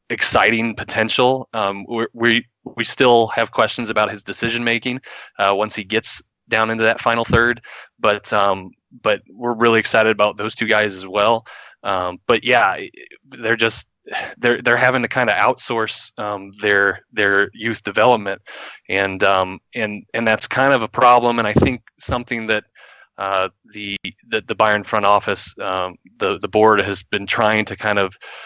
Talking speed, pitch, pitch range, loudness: 170 wpm, 110 Hz, 100-115 Hz, -18 LUFS